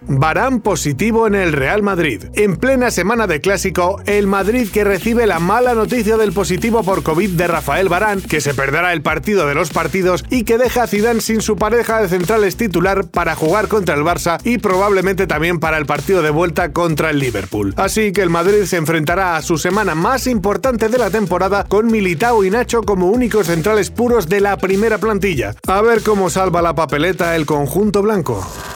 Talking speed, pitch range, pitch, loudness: 200 wpm, 170-215 Hz, 195 Hz, -15 LUFS